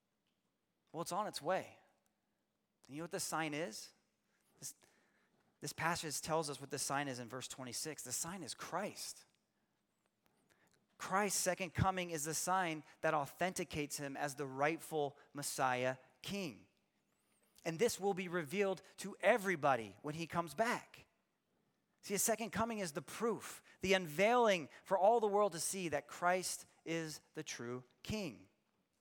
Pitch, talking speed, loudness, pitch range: 165 Hz, 155 wpm, -39 LUFS, 145-190 Hz